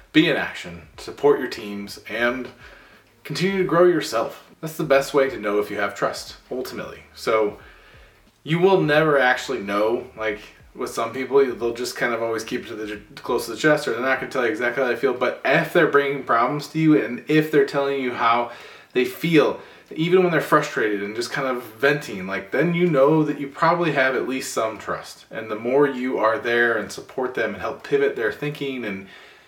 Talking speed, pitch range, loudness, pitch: 220 wpm, 115-155 Hz, -22 LUFS, 135 Hz